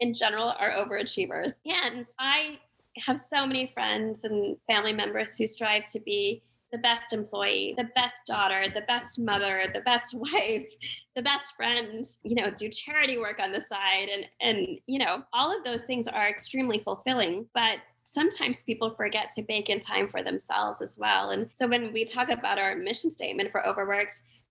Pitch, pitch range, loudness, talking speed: 230 Hz, 210-255 Hz, -26 LUFS, 180 wpm